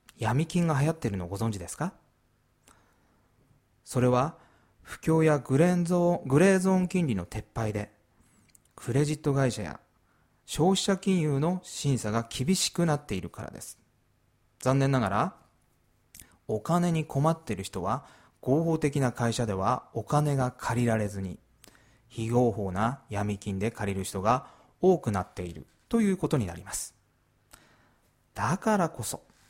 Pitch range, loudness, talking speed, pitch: 105-150 Hz, -28 LUFS, 265 characters per minute, 120 Hz